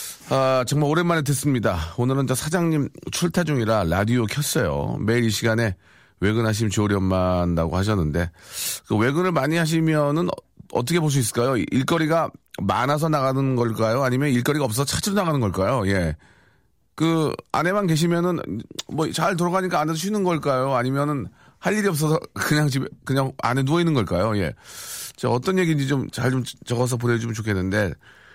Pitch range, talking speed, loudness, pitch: 110-160 Hz, 360 characters per minute, -22 LUFS, 135 Hz